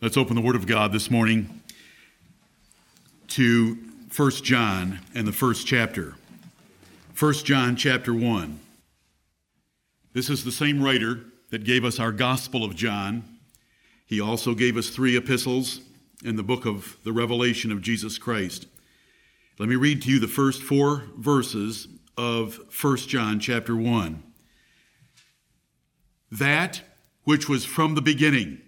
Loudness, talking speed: -24 LUFS, 140 wpm